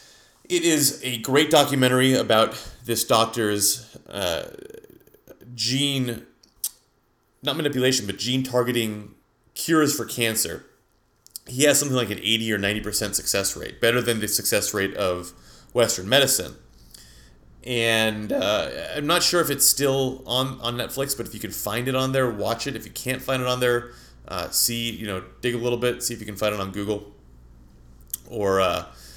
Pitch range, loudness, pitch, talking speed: 105-130 Hz, -23 LUFS, 120 Hz, 170 wpm